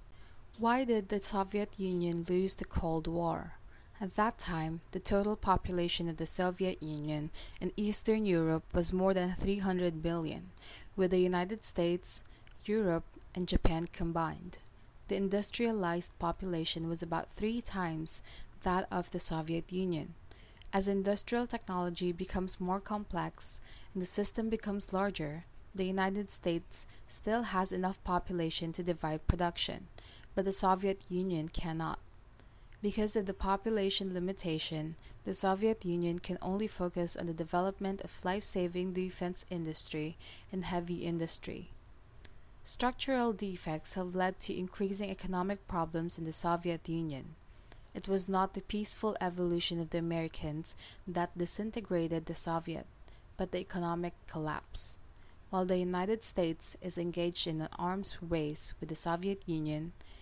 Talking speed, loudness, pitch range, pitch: 135 wpm, -35 LUFS, 165-195 Hz, 180 Hz